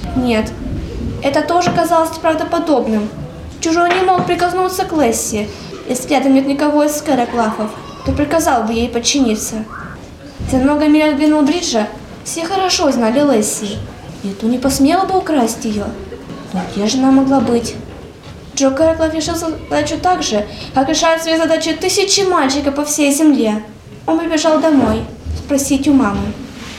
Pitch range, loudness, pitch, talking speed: 245-325 Hz, -15 LUFS, 290 Hz, 145 wpm